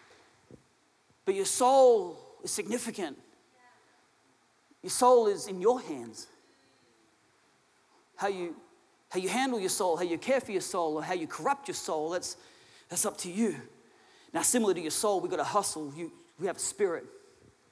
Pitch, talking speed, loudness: 240 Hz, 160 wpm, -30 LUFS